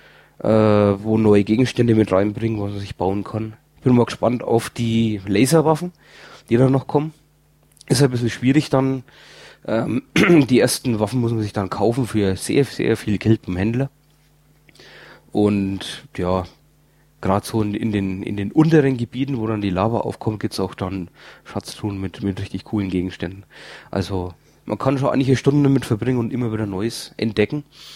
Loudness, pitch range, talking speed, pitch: -20 LUFS, 100-135 Hz, 180 wpm, 110 Hz